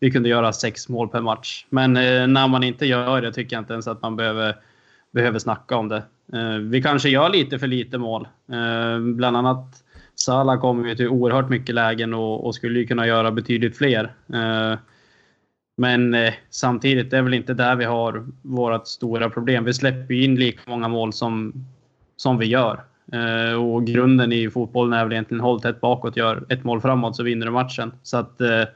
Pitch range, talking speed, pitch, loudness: 115-125 Hz, 205 wpm, 120 Hz, -21 LUFS